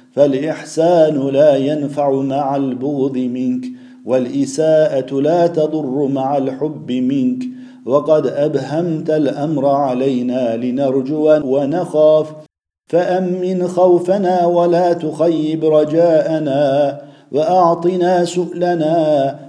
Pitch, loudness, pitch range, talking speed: 155 Hz, -15 LUFS, 140-170 Hz, 75 wpm